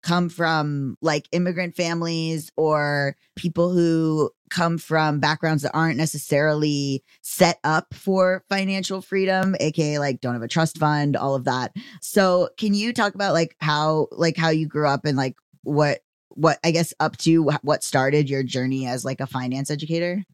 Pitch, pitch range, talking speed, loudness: 155 Hz, 145-170 Hz, 170 wpm, -22 LUFS